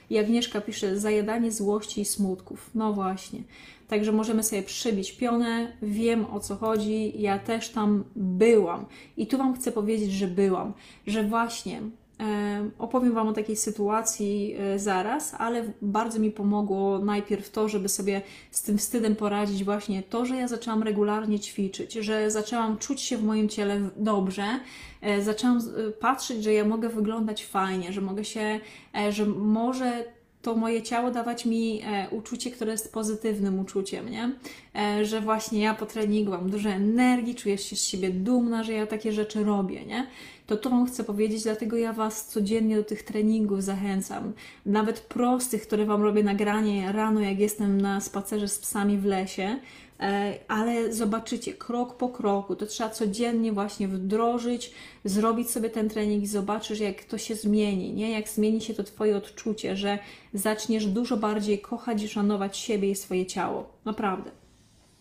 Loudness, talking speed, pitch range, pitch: -27 LUFS, 160 wpm, 205-225 Hz, 215 Hz